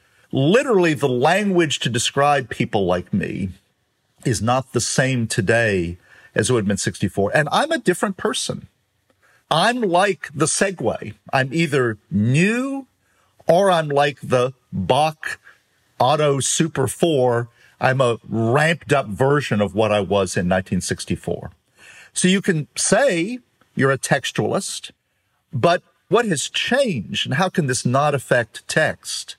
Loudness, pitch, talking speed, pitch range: -19 LUFS, 135 Hz, 135 wpm, 115-165 Hz